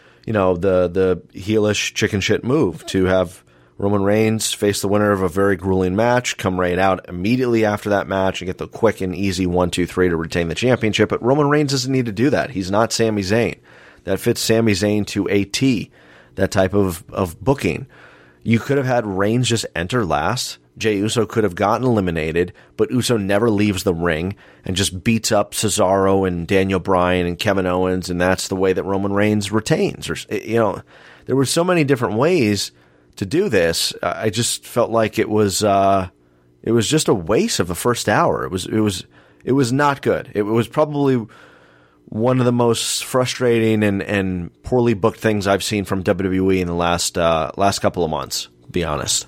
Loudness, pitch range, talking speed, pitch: -18 LUFS, 95-115 Hz, 200 wpm, 100 Hz